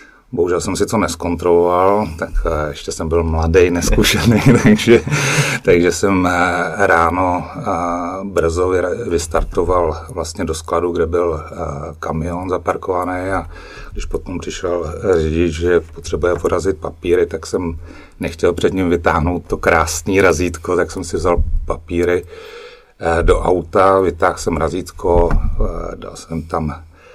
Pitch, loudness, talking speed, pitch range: 85 Hz, -16 LUFS, 125 wpm, 85-95 Hz